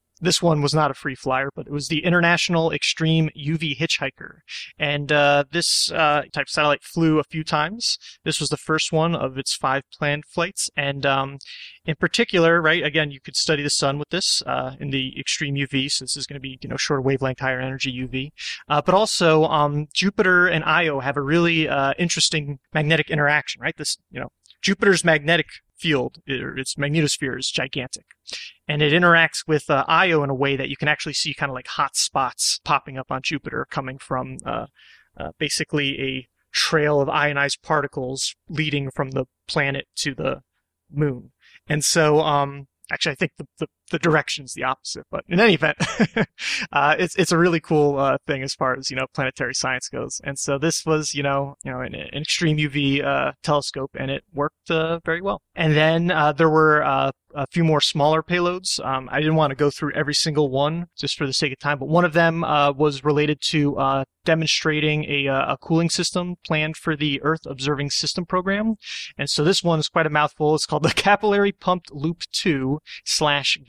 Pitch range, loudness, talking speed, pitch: 140-165 Hz, -21 LUFS, 205 wpm, 150 Hz